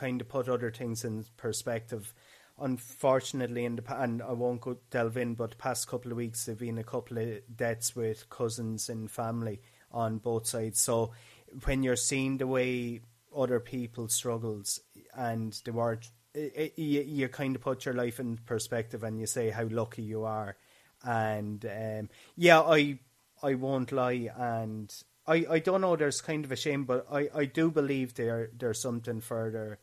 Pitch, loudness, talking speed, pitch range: 120 Hz, -32 LUFS, 180 wpm, 115-130 Hz